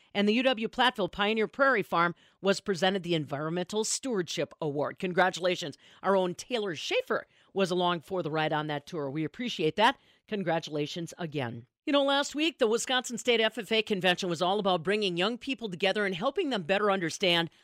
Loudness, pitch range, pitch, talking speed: -29 LUFS, 175-225 Hz, 195 Hz, 175 wpm